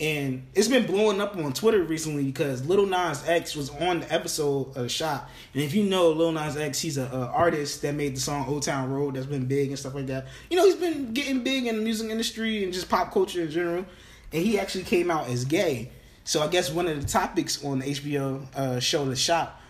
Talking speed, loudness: 240 wpm, -26 LUFS